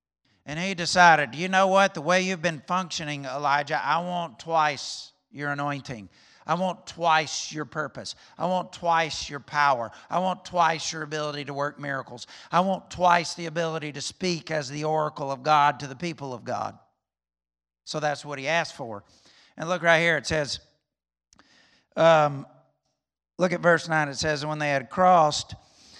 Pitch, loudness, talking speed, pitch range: 155 Hz, -25 LUFS, 175 wpm, 140-170 Hz